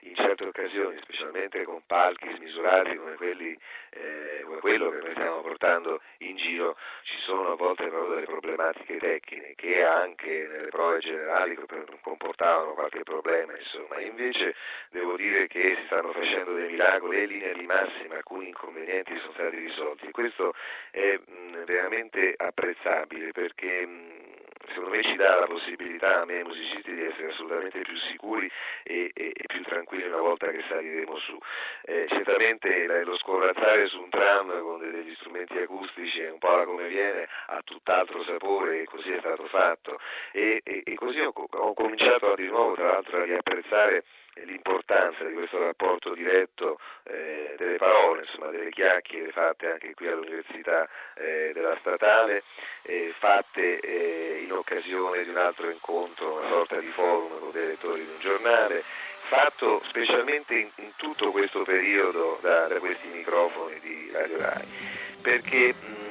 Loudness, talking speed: -27 LUFS, 155 wpm